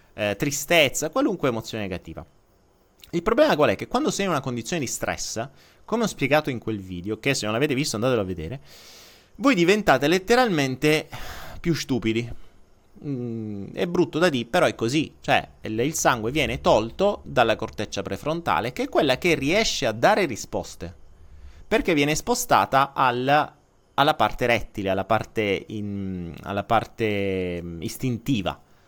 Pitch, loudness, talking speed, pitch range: 115 Hz, -23 LUFS, 155 wpm, 100-150 Hz